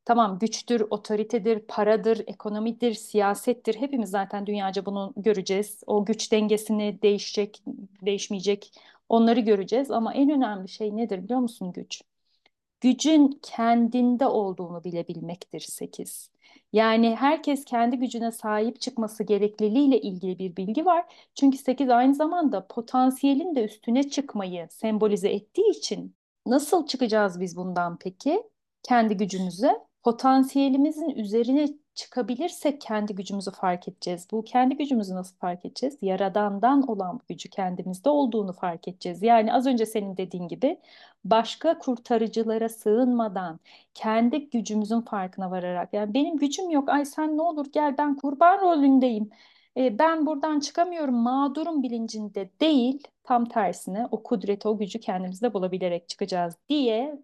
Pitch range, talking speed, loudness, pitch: 205-270 Hz, 130 wpm, -25 LUFS, 230 Hz